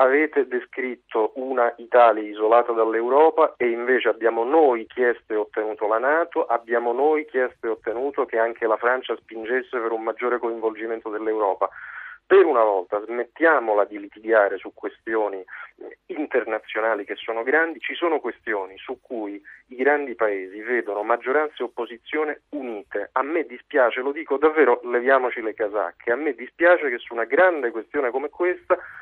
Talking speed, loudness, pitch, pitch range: 155 wpm, -22 LUFS, 120 Hz, 110-145 Hz